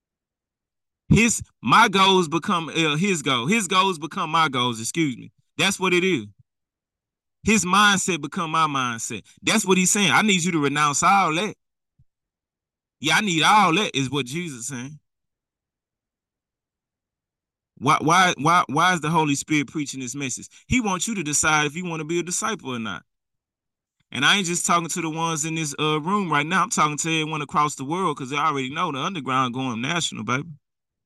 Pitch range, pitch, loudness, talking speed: 135-180 Hz, 160 Hz, -21 LUFS, 190 wpm